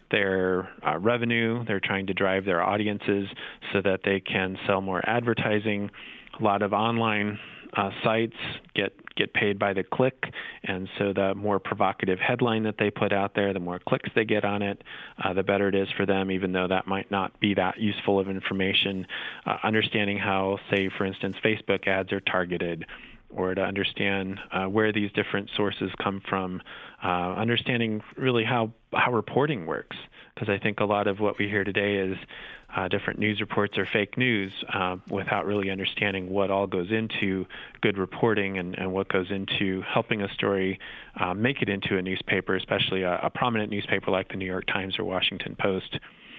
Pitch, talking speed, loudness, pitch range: 100 Hz, 190 wpm, -27 LUFS, 95-105 Hz